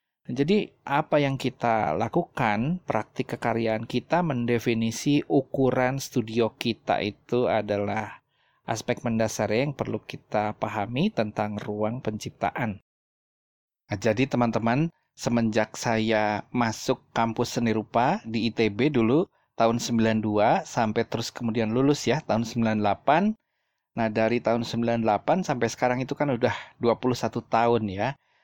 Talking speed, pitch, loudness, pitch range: 120 wpm, 115 Hz, -26 LUFS, 110-130 Hz